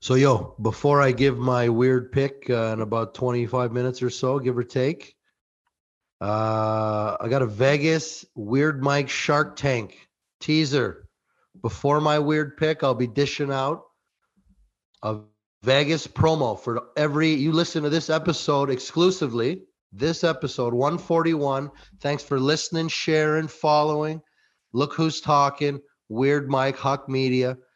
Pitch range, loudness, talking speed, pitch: 125-150 Hz, -23 LUFS, 135 wpm, 140 Hz